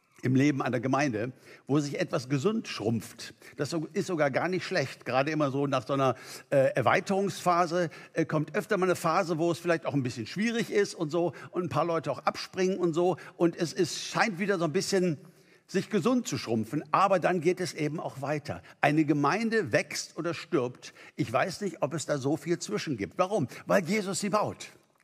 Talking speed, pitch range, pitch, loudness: 210 wpm, 145-190 Hz, 170 Hz, -29 LUFS